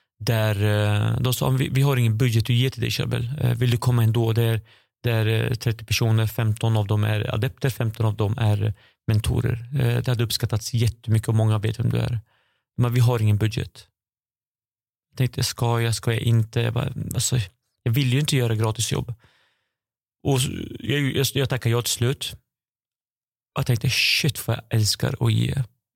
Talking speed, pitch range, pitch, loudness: 175 wpm, 110-125 Hz, 120 Hz, -23 LUFS